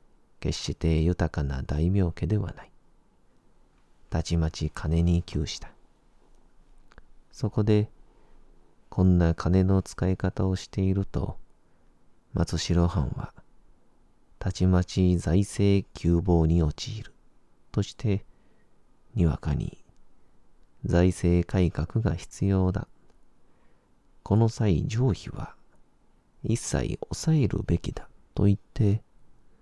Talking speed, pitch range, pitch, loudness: 175 characters per minute, 80-100 Hz, 90 Hz, -27 LUFS